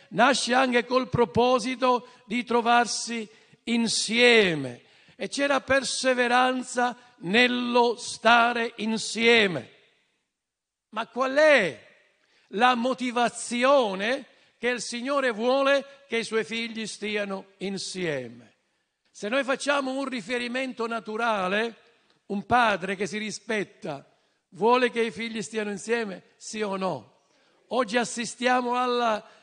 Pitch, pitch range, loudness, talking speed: 235 Hz, 210-250 Hz, -25 LUFS, 105 wpm